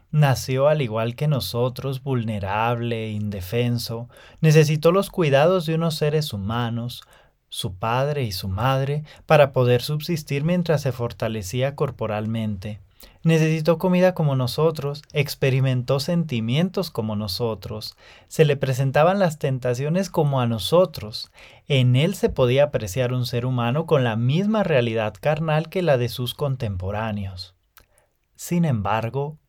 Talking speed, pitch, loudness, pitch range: 125 wpm, 130 Hz, -22 LUFS, 115-155 Hz